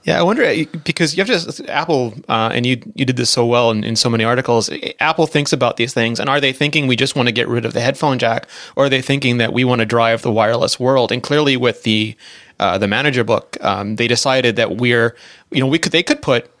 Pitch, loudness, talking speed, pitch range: 125 Hz, -16 LUFS, 260 wpm, 115-140 Hz